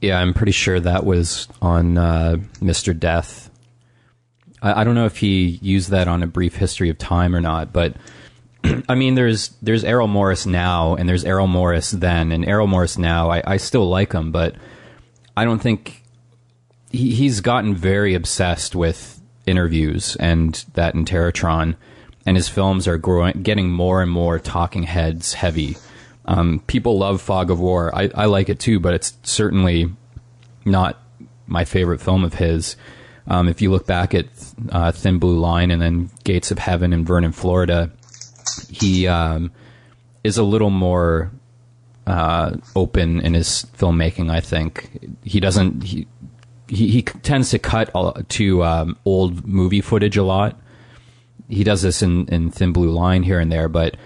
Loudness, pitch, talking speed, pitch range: -18 LUFS, 95 Hz, 170 wpm, 85-110 Hz